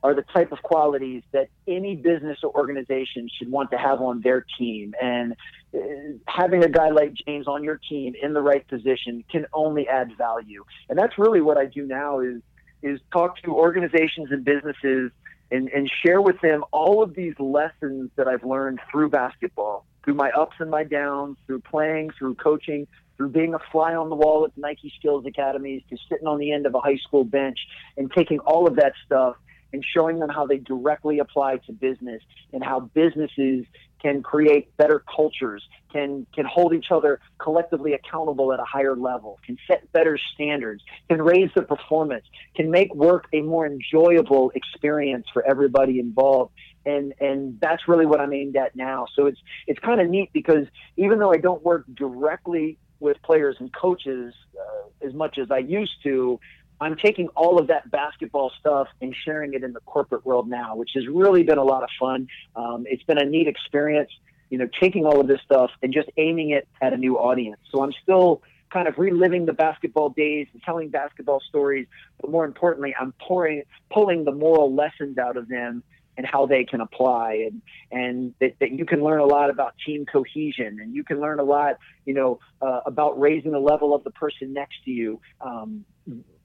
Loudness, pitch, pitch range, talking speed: -22 LUFS, 145 Hz, 130-160 Hz, 195 wpm